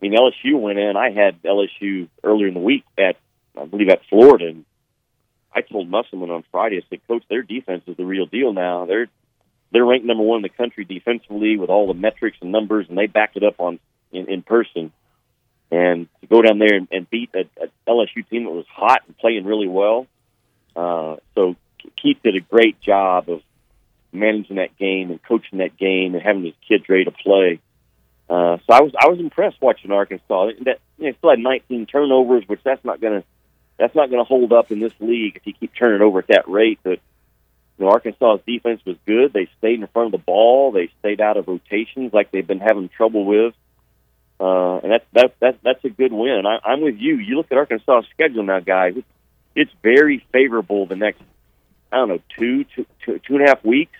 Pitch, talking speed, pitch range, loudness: 105 Hz, 220 wpm, 90-120 Hz, -17 LUFS